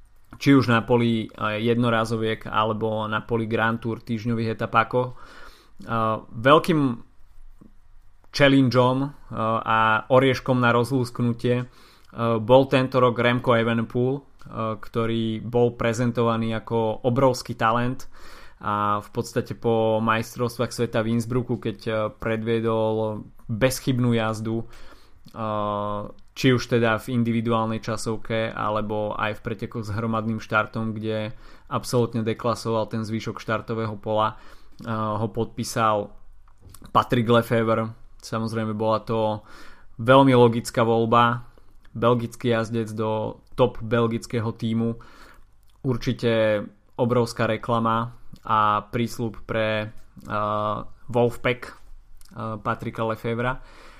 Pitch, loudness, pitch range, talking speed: 115 Hz, -23 LUFS, 110-120 Hz, 100 wpm